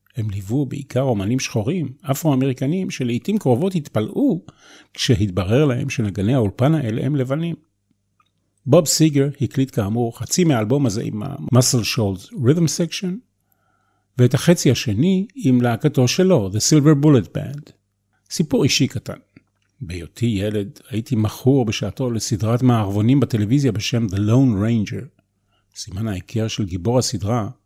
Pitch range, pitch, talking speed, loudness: 105-140 Hz, 125 Hz, 125 wpm, -19 LUFS